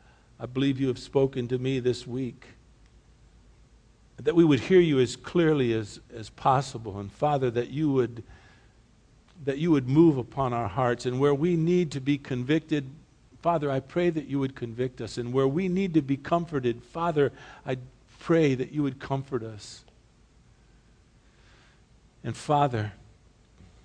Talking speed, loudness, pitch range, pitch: 160 wpm, -27 LUFS, 120-145 Hz, 130 Hz